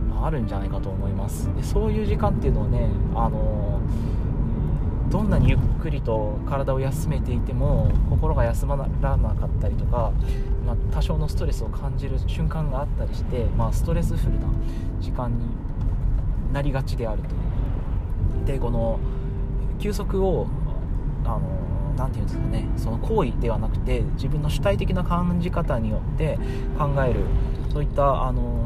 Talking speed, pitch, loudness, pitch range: 325 characters per minute, 110 Hz, -25 LUFS, 90-125 Hz